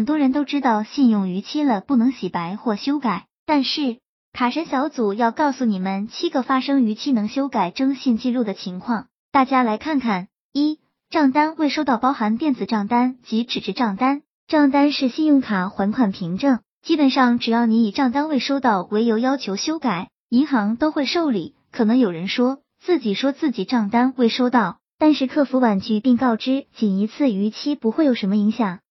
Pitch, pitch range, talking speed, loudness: 250 Hz, 220-280 Hz, 285 characters per minute, -20 LUFS